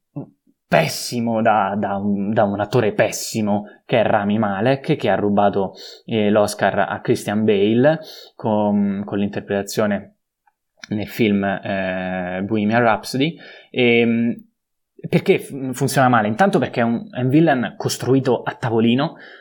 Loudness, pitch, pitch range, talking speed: -19 LUFS, 110 Hz, 100-130 Hz, 125 wpm